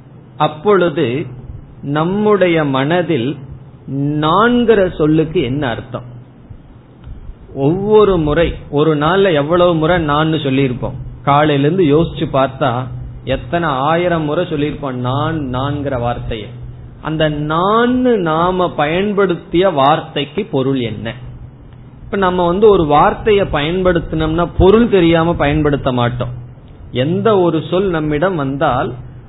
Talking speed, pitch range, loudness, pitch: 90 wpm, 130-175 Hz, -14 LUFS, 150 Hz